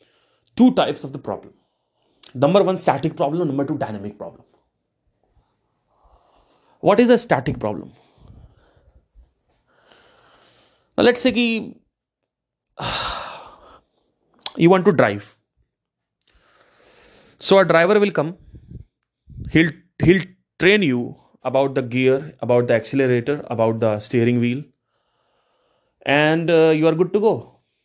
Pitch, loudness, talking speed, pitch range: 145 Hz, -18 LUFS, 110 wpm, 120-185 Hz